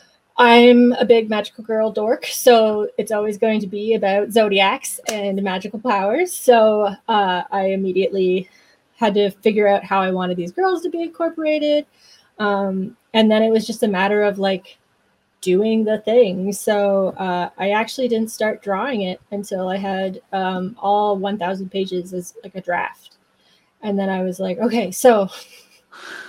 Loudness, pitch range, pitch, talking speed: -18 LUFS, 190-225 Hz, 205 Hz, 165 wpm